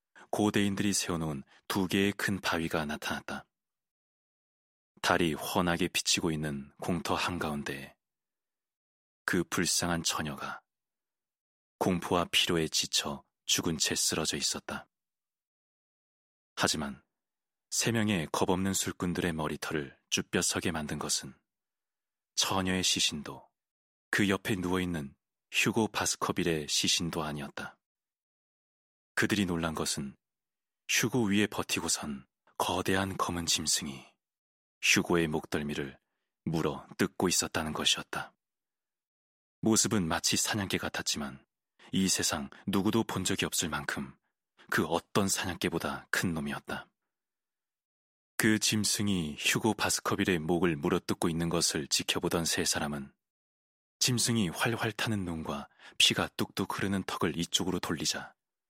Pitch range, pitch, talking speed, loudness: 80-100 Hz, 90 Hz, 250 characters per minute, -30 LUFS